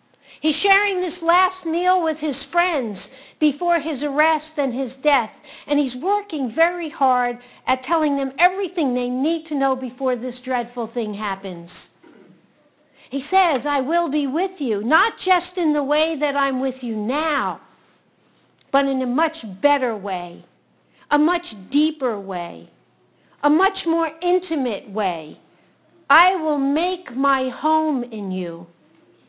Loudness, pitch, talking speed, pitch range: -20 LUFS, 290 Hz, 145 wpm, 250-330 Hz